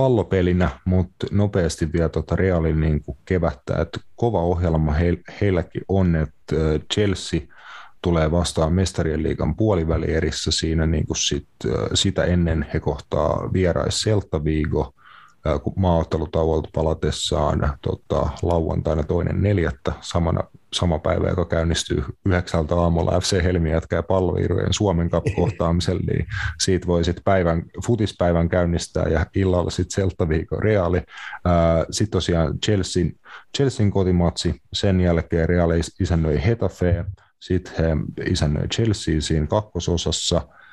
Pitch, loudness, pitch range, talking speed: 85 Hz, -22 LUFS, 80-95 Hz, 110 wpm